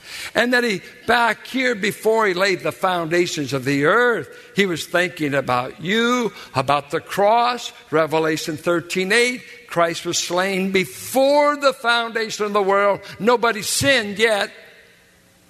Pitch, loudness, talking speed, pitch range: 200 Hz, -19 LUFS, 135 wpm, 170-235 Hz